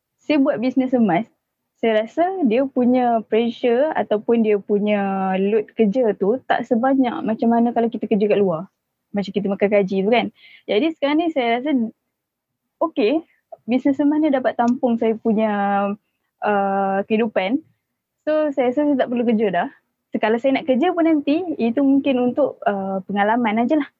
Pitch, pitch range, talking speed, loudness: 235 Hz, 210-275 Hz, 165 wpm, -20 LUFS